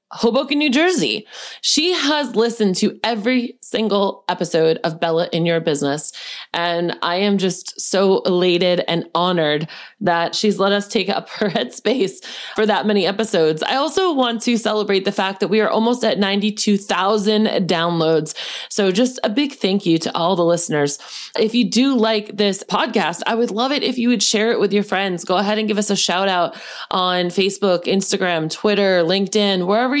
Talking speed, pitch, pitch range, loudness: 180 wpm, 200 Hz, 180-225 Hz, -18 LUFS